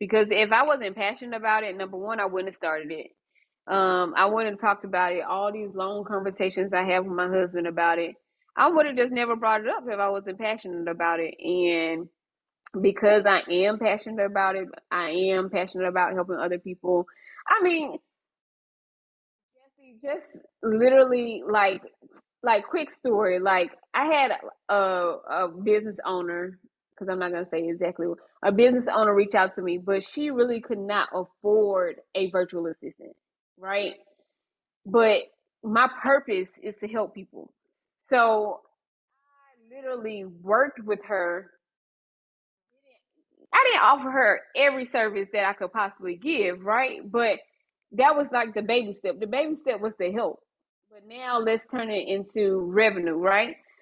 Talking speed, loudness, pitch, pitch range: 165 wpm, -25 LUFS, 205 Hz, 185-240 Hz